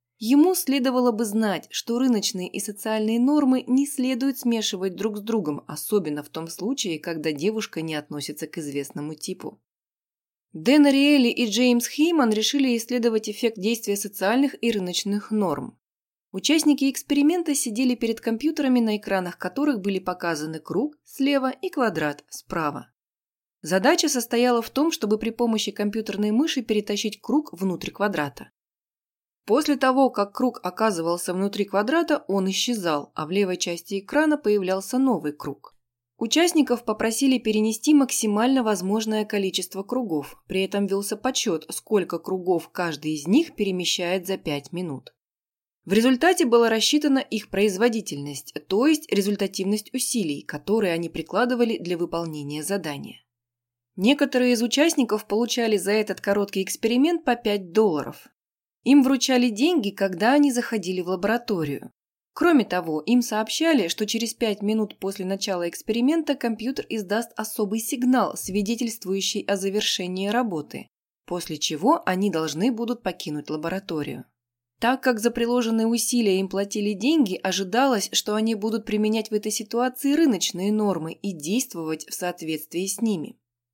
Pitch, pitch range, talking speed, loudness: 215 Hz, 185-245 Hz, 135 wpm, -23 LUFS